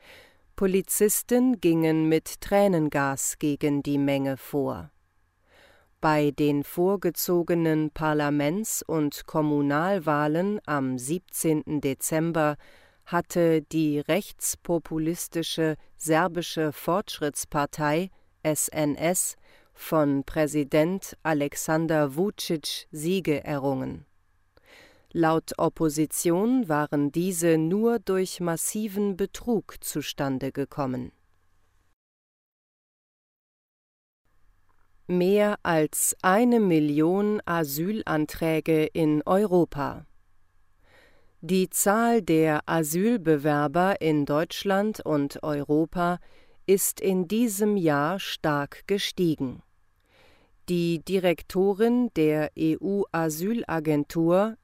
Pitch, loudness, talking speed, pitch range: 160 Hz, -25 LUFS, 70 wpm, 145-185 Hz